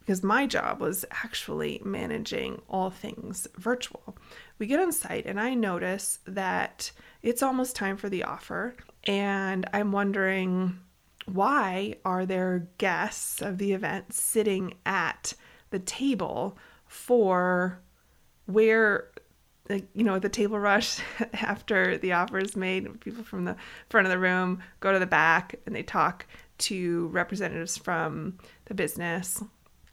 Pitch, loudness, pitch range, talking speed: 195 Hz, -28 LUFS, 185-220 Hz, 135 wpm